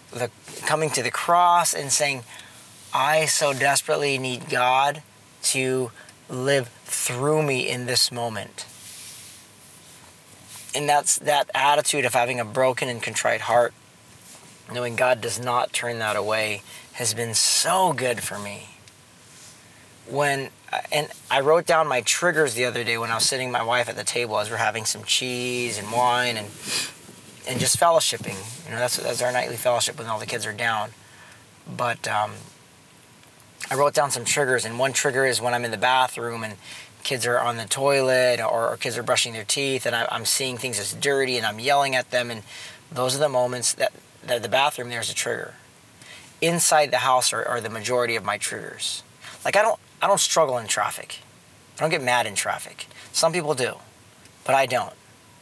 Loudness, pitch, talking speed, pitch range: -22 LUFS, 125 Hz, 185 wpm, 115-140 Hz